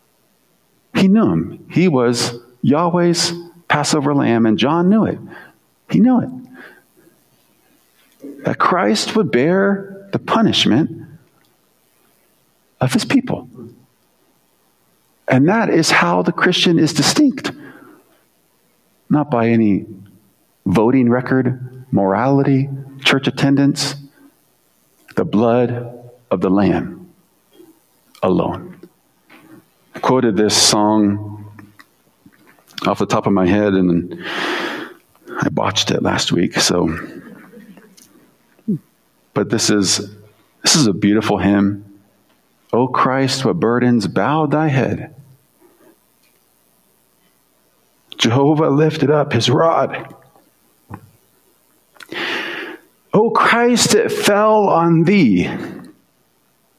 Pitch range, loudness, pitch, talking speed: 110-170 Hz, -16 LUFS, 135 Hz, 95 wpm